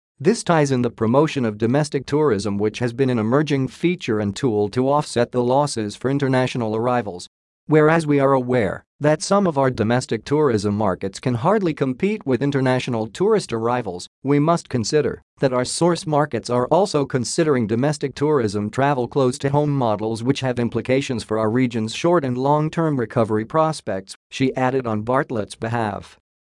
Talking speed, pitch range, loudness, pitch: 170 wpm, 115-145 Hz, -20 LUFS, 130 Hz